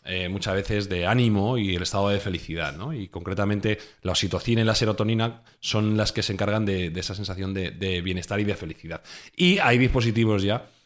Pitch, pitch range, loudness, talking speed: 100 Hz, 95-110 Hz, -25 LUFS, 205 wpm